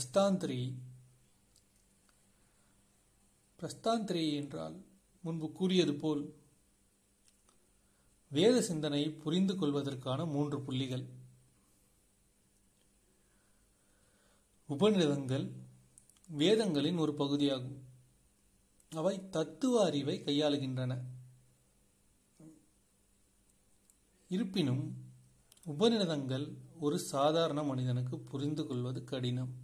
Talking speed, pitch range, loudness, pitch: 50 wpm, 100-155 Hz, -34 LUFS, 135 Hz